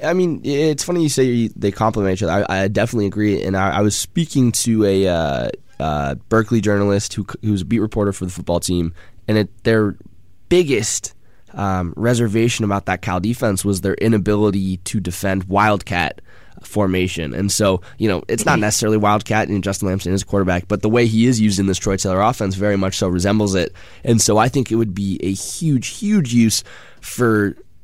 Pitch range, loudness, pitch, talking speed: 95-110 Hz, -18 LUFS, 105 Hz, 200 wpm